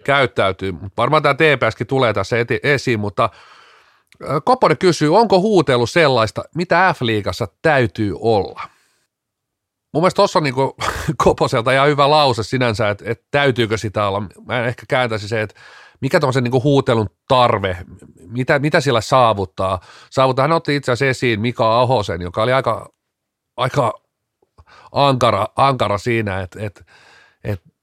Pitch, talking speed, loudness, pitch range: 125 Hz, 135 wpm, -17 LUFS, 110-140 Hz